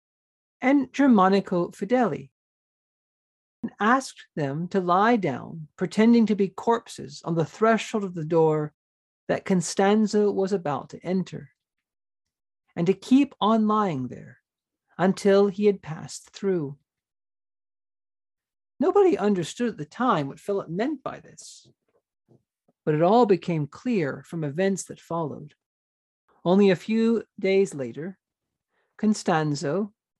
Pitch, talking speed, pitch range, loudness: 190 Hz, 120 wpm, 150-215 Hz, -24 LUFS